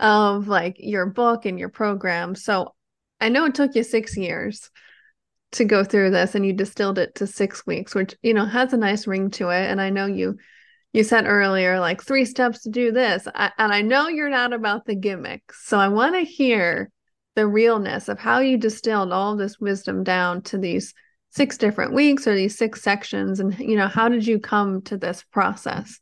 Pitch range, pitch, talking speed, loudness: 195-240 Hz, 210 Hz, 210 wpm, -21 LUFS